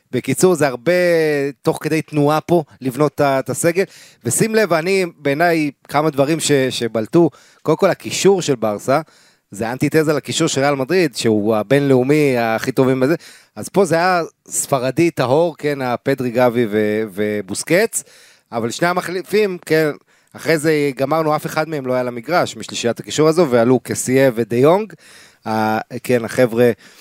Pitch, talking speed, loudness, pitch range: 140 Hz, 155 wpm, -17 LUFS, 120-160 Hz